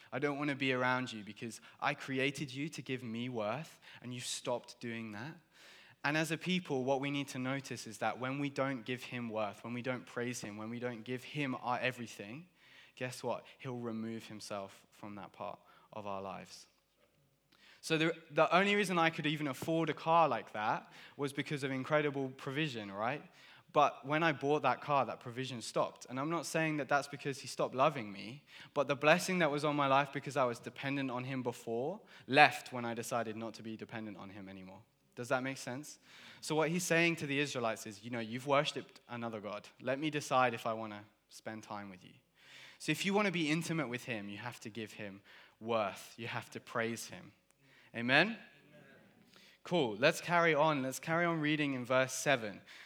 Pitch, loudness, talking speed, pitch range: 130 Hz, -36 LUFS, 210 wpm, 115-150 Hz